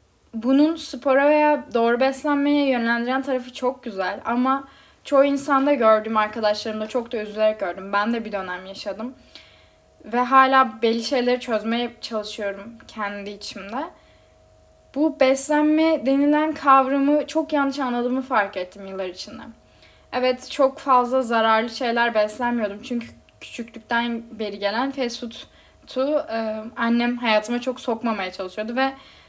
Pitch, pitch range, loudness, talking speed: 240 Hz, 220-270 Hz, -22 LUFS, 125 wpm